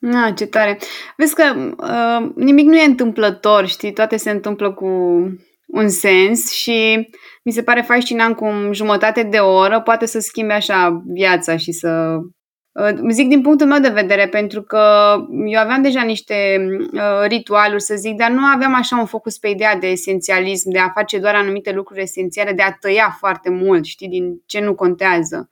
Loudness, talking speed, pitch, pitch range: -15 LUFS, 185 wpm, 210 Hz, 190-230 Hz